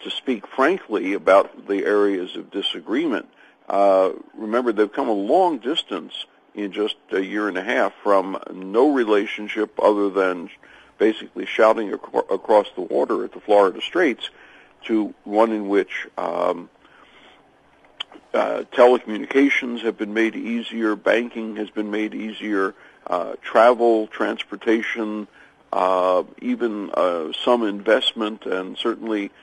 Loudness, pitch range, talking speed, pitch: -21 LUFS, 100-115 Hz, 130 wpm, 105 Hz